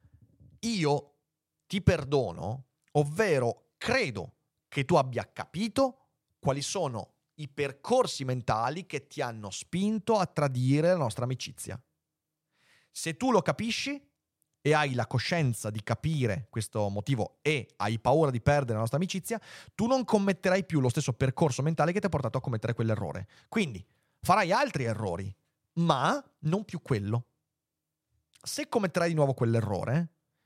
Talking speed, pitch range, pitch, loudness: 140 wpm, 120-175 Hz, 145 Hz, -30 LUFS